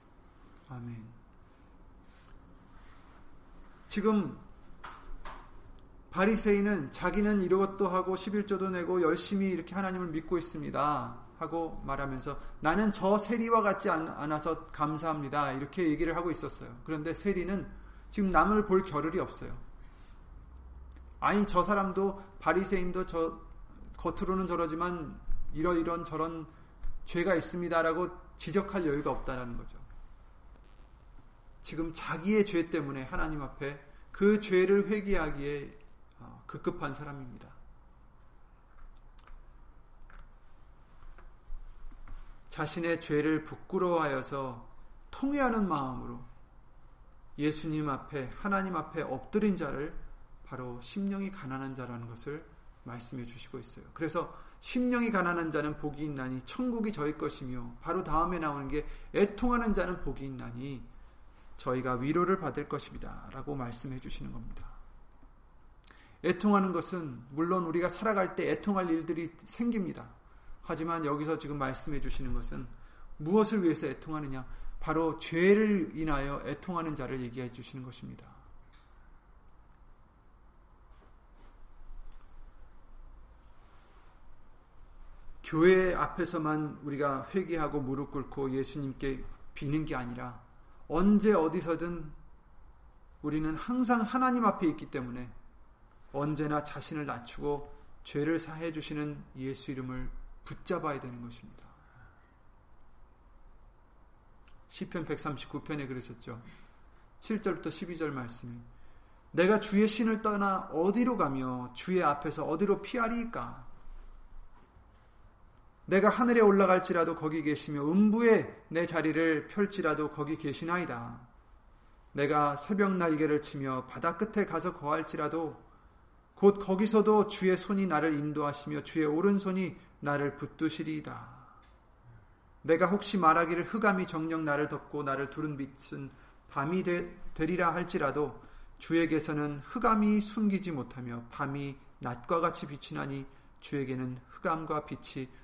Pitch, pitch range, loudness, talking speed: 155 Hz, 135-180 Hz, -32 LUFS, 260 characters per minute